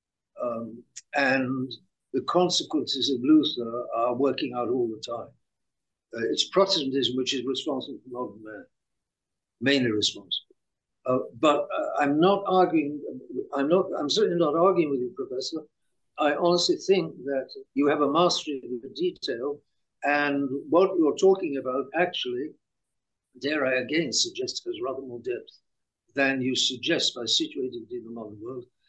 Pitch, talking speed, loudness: 150 Hz, 150 wpm, -26 LUFS